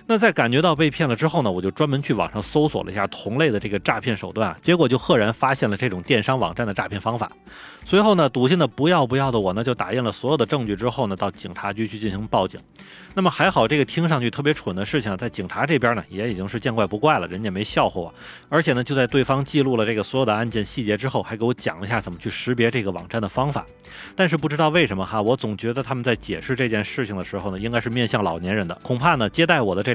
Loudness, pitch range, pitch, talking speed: -22 LUFS, 105-145 Hz, 120 Hz, 410 characters per minute